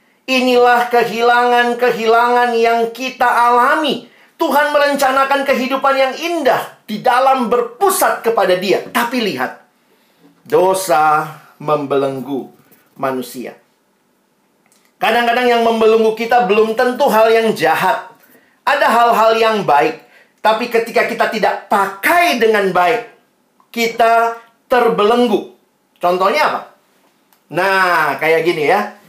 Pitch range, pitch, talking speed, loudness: 210-245 Hz, 230 Hz, 100 wpm, -14 LUFS